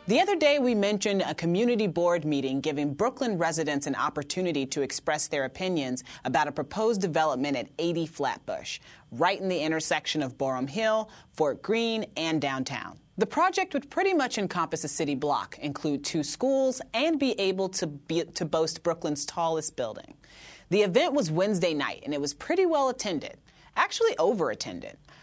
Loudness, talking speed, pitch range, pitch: -28 LUFS, 170 wpm, 150-220 Hz, 170 Hz